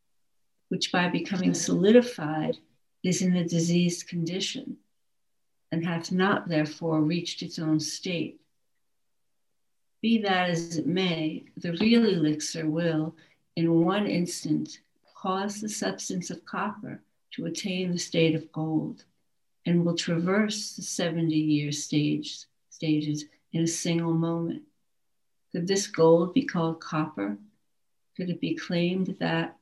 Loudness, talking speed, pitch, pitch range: -27 LUFS, 125 wpm, 170 Hz, 155-185 Hz